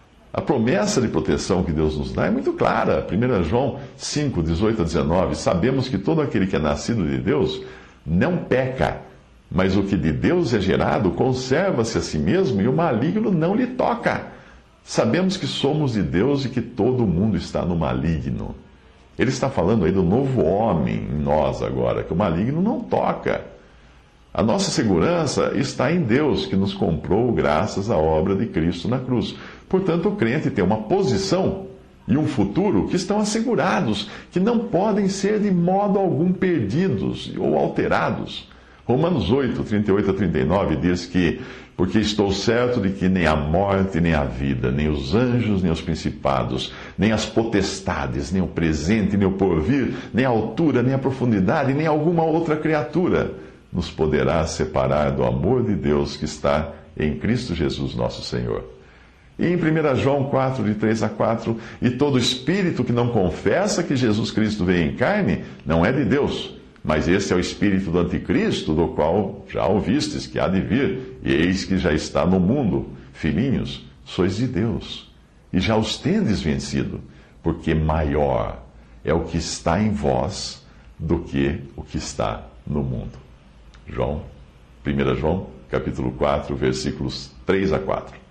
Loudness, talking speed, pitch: -21 LUFS, 170 wpm, 95 Hz